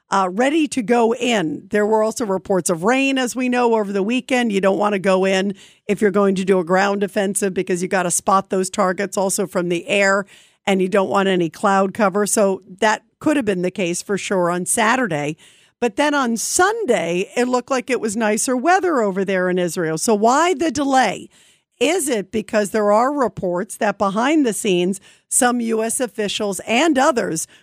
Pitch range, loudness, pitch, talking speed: 190-240 Hz, -18 LUFS, 205 Hz, 205 wpm